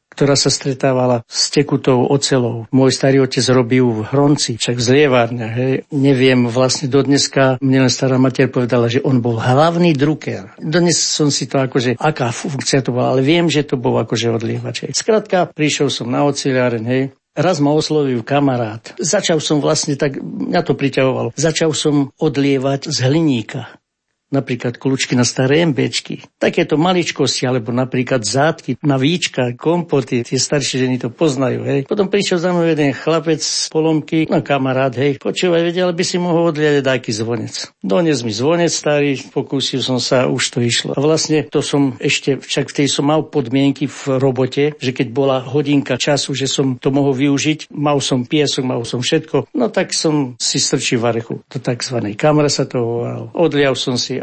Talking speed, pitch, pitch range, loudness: 175 wpm, 140 Hz, 130-150 Hz, -16 LUFS